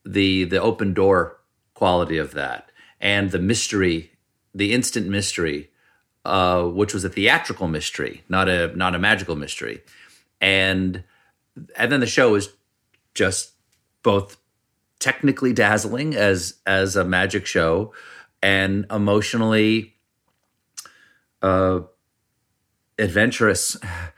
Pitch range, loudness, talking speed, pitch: 95-110 Hz, -20 LUFS, 110 wpm, 100 Hz